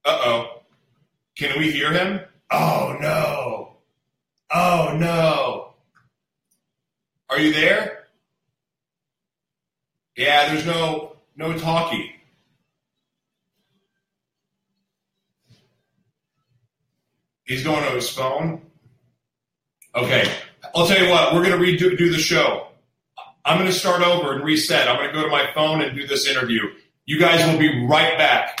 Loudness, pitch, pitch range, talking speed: -19 LUFS, 155 Hz, 145-170 Hz, 120 wpm